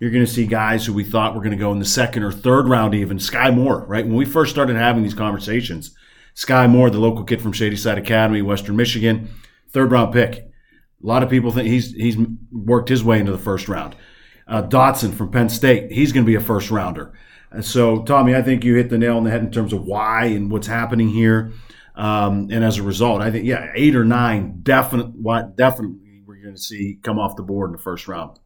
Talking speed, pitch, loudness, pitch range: 240 wpm, 115 Hz, -18 LUFS, 105-120 Hz